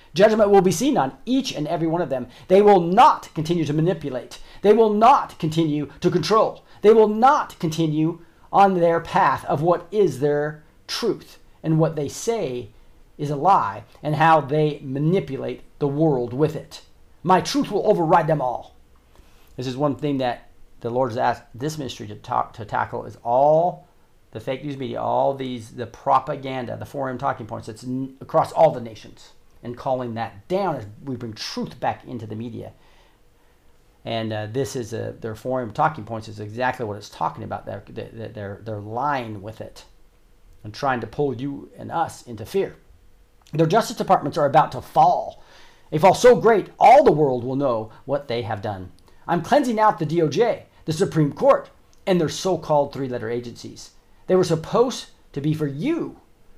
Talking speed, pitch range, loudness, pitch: 185 wpm, 115-170 Hz, -21 LUFS, 140 Hz